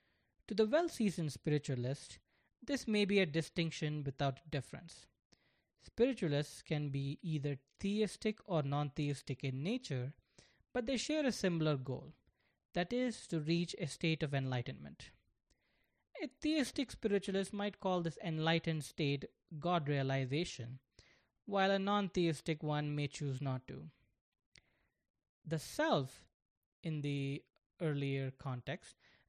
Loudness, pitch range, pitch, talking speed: -38 LUFS, 140-195 Hz, 160 Hz, 125 wpm